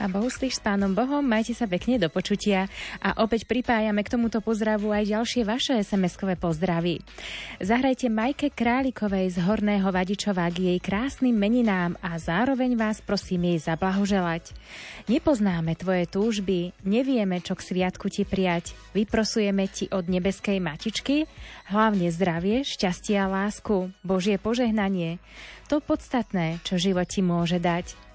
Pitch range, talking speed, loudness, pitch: 185-225 Hz, 140 wpm, -25 LUFS, 200 Hz